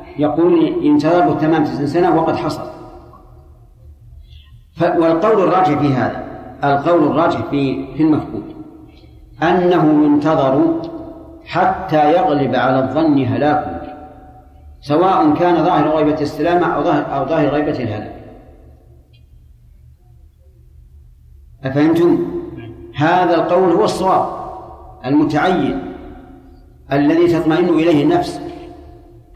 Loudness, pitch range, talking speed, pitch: -15 LUFS, 130-180 Hz, 90 wpm, 155 Hz